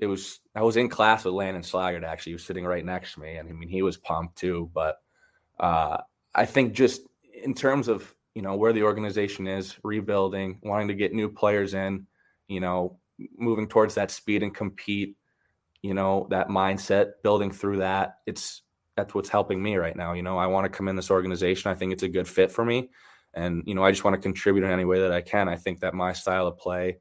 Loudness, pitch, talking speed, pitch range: -26 LUFS, 95 Hz, 235 wpm, 90-105 Hz